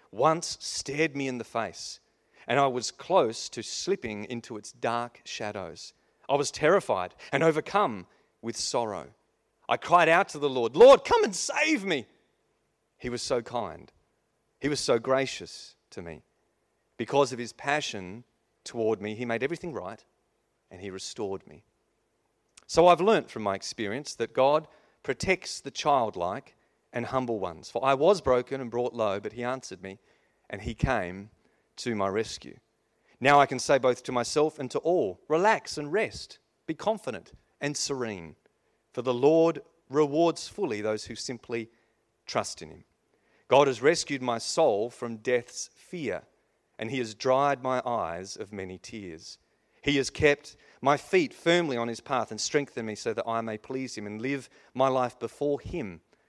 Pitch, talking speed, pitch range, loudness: 125 Hz, 170 wpm, 115-145 Hz, -27 LUFS